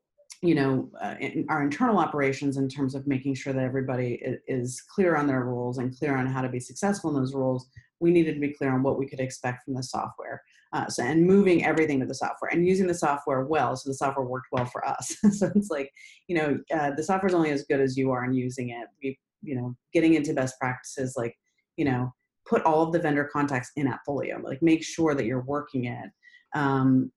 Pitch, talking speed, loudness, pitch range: 135 Hz, 235 wpm, -27 LUFS, 130-160 Hz